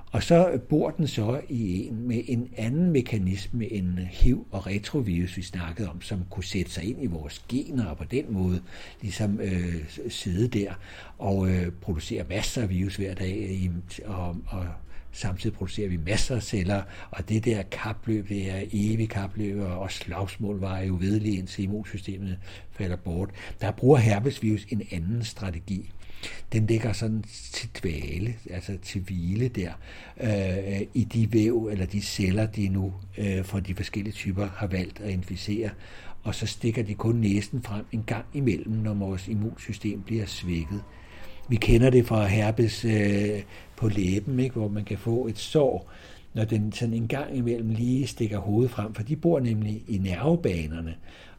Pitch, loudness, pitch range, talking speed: 100 Hz, -28 LUFS, 95-110 Hz, 170 wpm